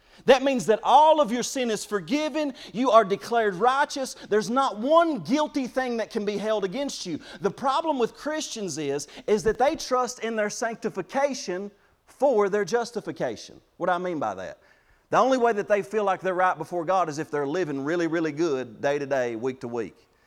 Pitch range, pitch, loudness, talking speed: 185-265 Hz, 215 Hz, -25 LUFS, 205 wpm